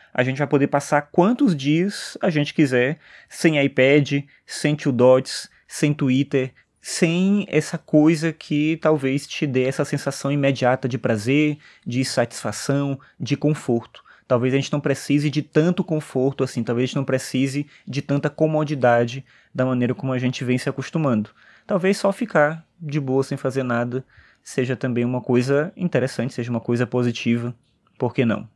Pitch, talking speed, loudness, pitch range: 140 Hz, 160 wpm, -21 LUFS, 125-150 Hz